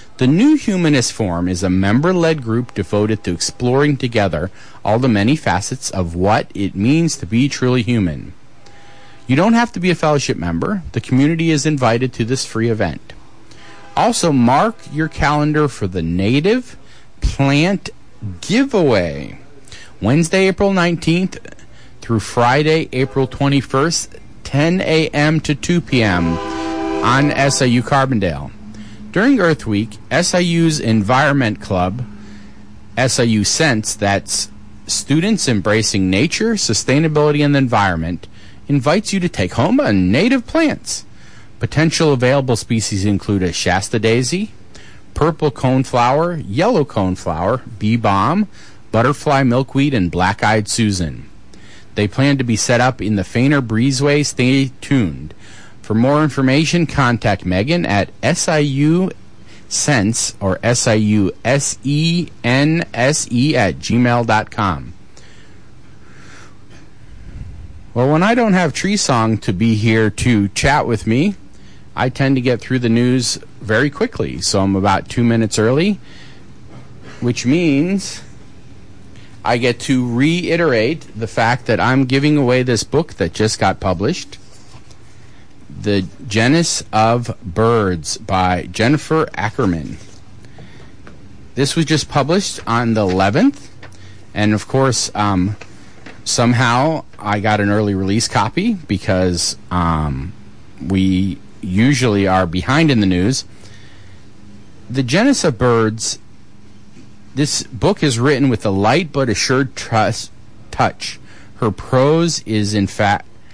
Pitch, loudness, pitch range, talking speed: 120 Hz, -16 LUFS, 100-145 Hz, 125 wpm